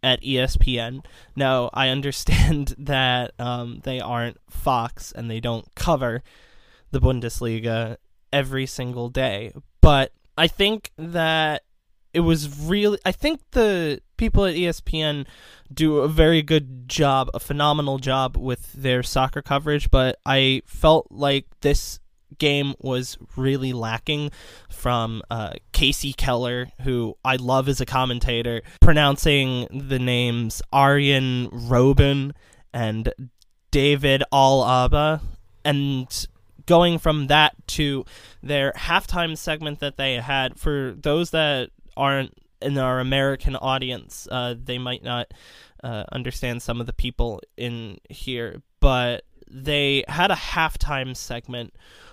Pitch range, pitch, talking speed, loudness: 120-145 Hz, 130 Hz, 125 wpm, -22 LUFS